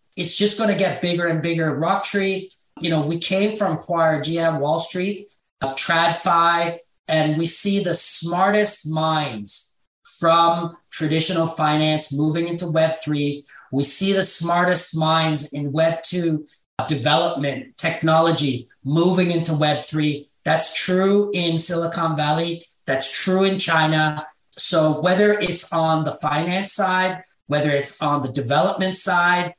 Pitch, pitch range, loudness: 165 Hz, 155-180 Hz, -19 LUFS